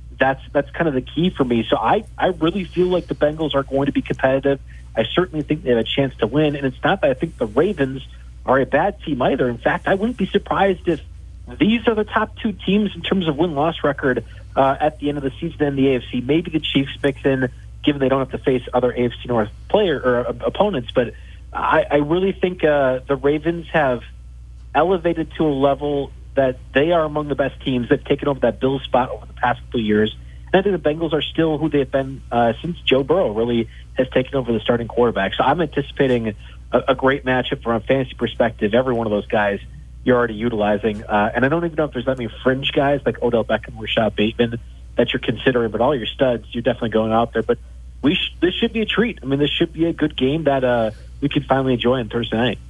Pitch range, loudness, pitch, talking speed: 120-150 Hz, -20 LUFS, 135 Hz, 245 wpm